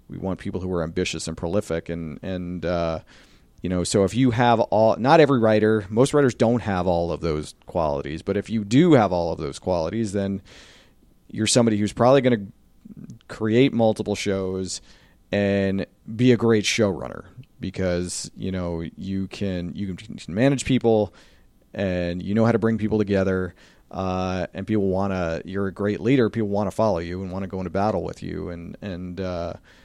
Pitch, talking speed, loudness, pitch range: 100 Hz, 190 wpm, -23 LUFS, 90-110 Hz